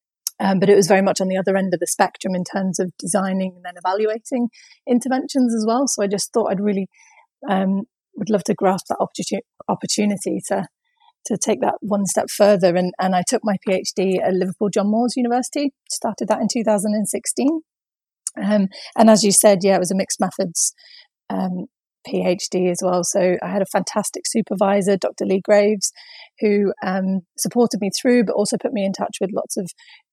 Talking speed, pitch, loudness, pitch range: 190 wpm, 200 Hz, -20 LUFS, 190-225 Hz